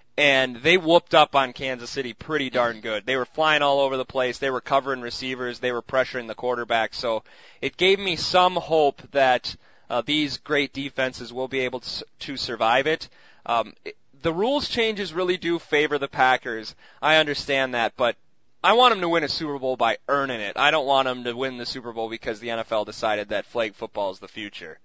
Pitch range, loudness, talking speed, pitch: 120-150 Hz, -23 LUFS, 215 wpm, 135 Hz